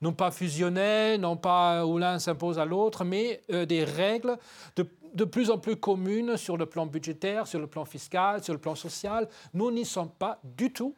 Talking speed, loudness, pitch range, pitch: 210 wpm, -29 LUFS, 165-215 Hz, 180 Hz